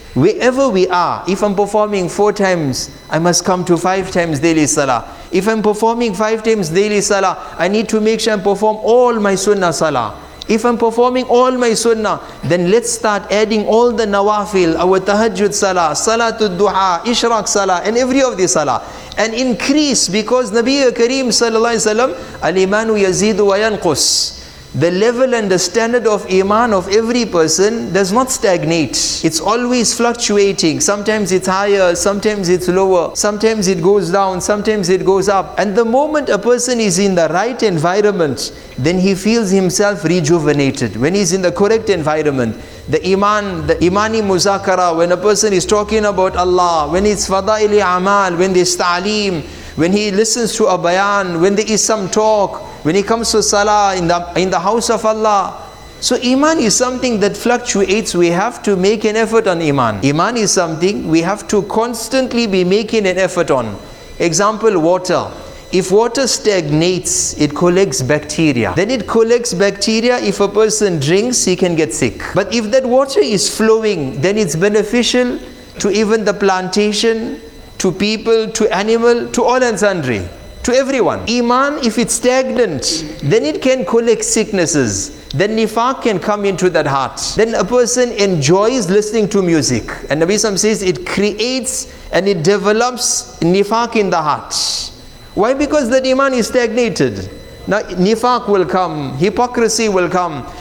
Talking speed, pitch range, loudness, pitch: 170 wpm, 180-225 Hz, -14 LUFS, 205 Hz